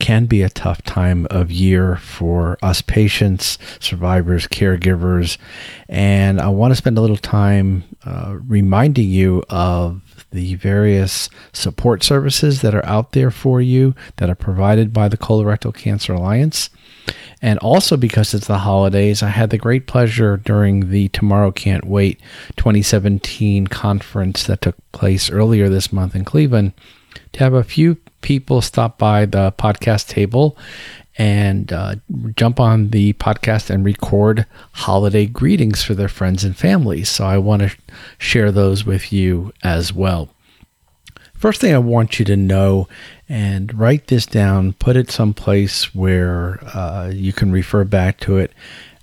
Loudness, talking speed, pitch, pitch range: -16 LUFS, 155 wpm, 100 Hz, 95-115 Hz